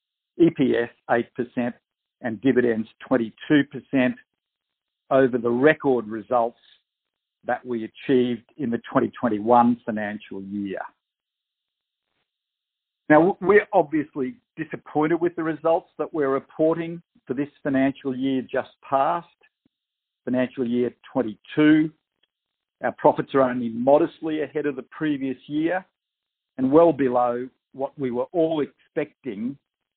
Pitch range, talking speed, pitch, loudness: 120-155 Hz, 110 wpm, 135 Hz, -23 LUFS